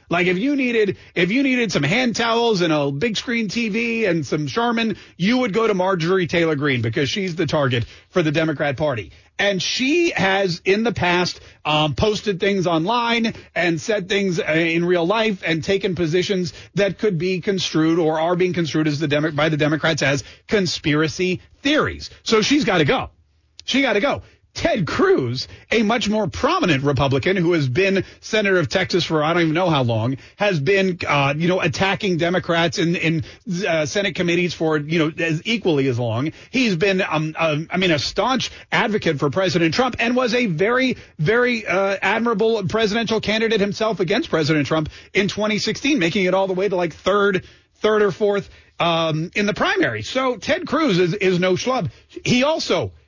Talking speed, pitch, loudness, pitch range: 190 wpm, 185 Hz, -19 LUFS, 160-215 Hz